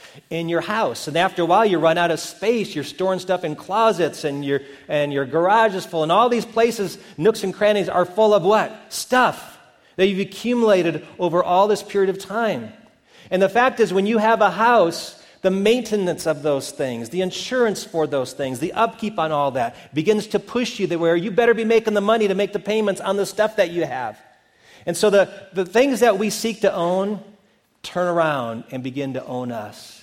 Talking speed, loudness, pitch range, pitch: 215 wpm, -20 LUFS, 165-215 Hz, 195 Hz